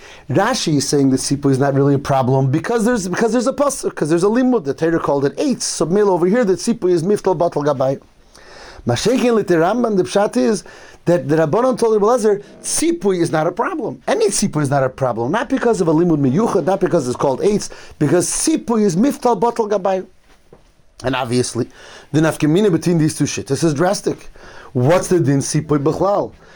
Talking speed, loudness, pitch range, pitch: 205 wpm, -17 LUFS, 145-215 Hz, 175 Hz